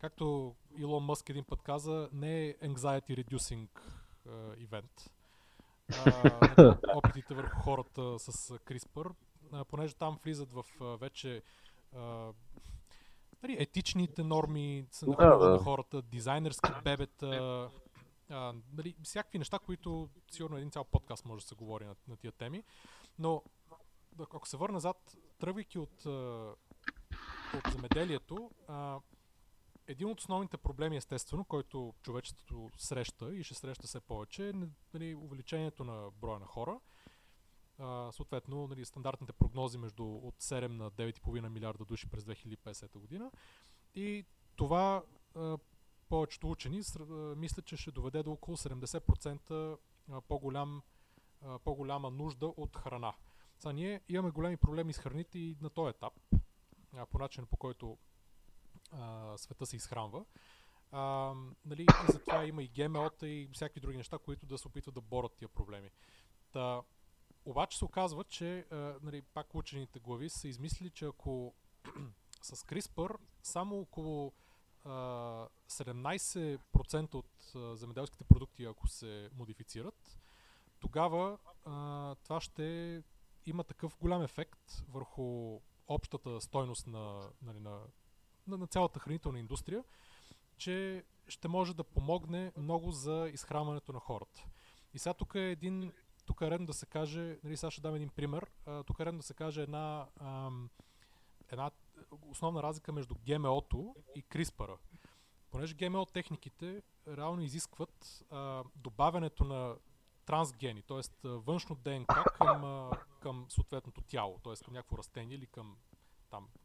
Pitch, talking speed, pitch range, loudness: 140 Hz, 135 wpm, 125-160 Hz, -37 LUFS